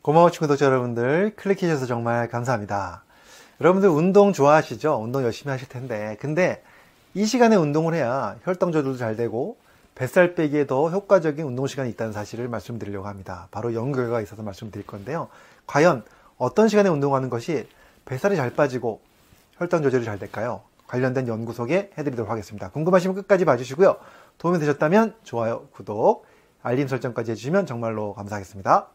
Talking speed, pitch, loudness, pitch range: 415 characters per minute, 130 Hz, -23 LUFS, 115-170 Hz